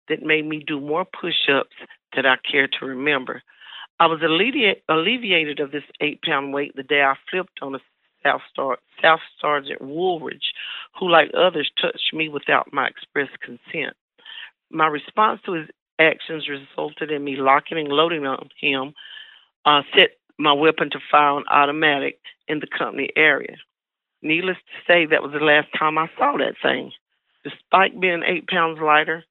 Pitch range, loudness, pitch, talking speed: 145-165 Hz, -20 LUFS, 155 Hz, 165 wpm